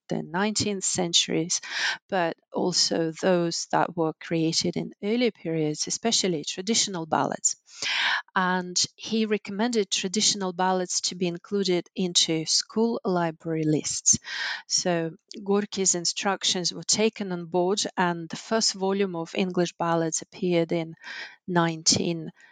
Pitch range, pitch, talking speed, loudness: 165-200 Hz, 180 Hz, 120 wpm, -25 LUFS